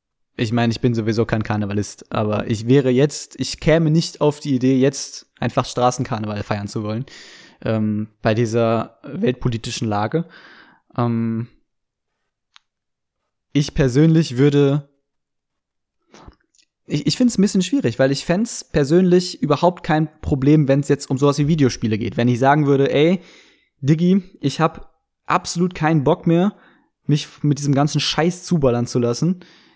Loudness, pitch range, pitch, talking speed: -19 LUFS, 120-155 Hz, 140 Hz, 150 wpm